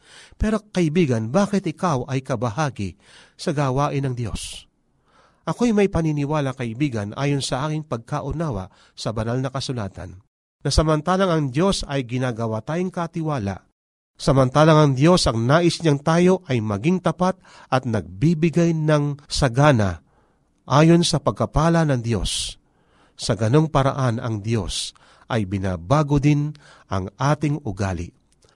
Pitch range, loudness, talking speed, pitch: 115-160 Hz, -21 LUFS, 125 wpm, 140 Hz